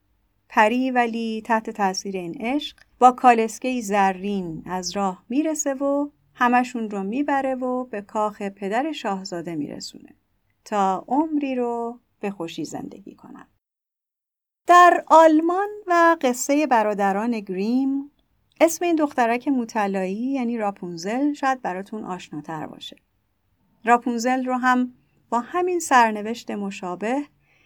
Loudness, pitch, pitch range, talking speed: -22 LUFS, 235 Hz, 200-270 Hz, 115 wpm